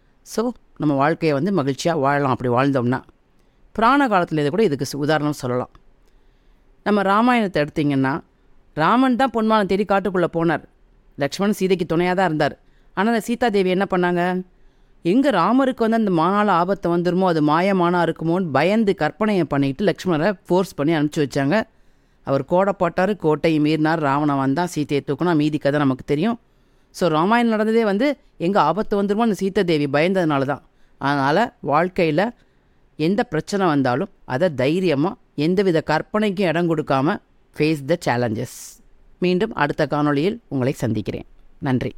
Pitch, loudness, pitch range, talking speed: 170 Hz, -20 LUFS, 145-200 Hz, 135 wpm